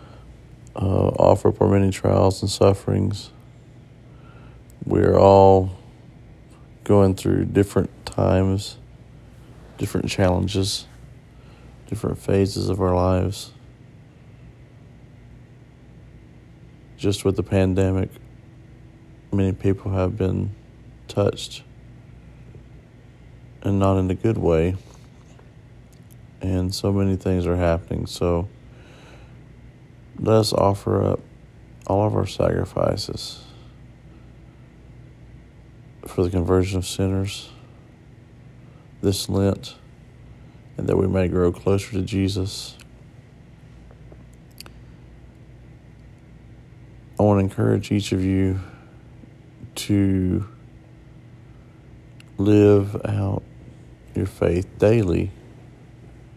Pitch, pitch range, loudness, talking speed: 100 Hz, 95-120 Hz, -21 LUFS, 85 wpm